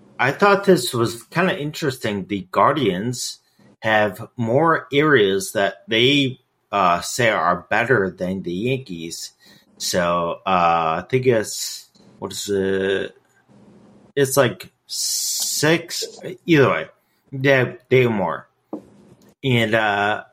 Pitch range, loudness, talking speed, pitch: 95-140 Hz, -19 LUFS, 115 wpm, 125 Hz